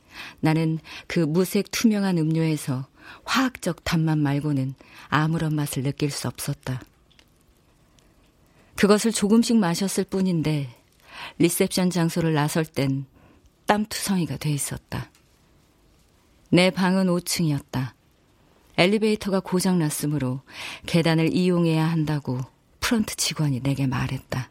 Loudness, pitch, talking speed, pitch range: -24 LUFS, 160 Hz, 250 characters per minute, 140-185 Hz